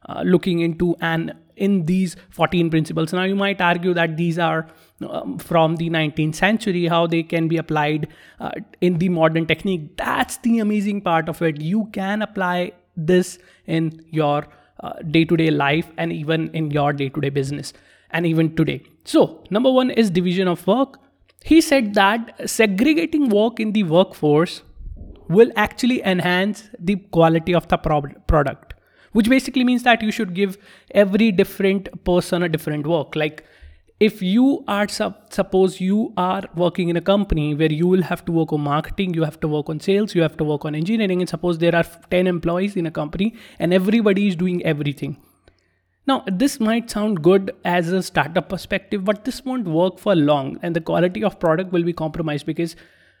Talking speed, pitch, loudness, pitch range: 185 wpm, 175 Hz, -20 LUFS, 160-200 Hz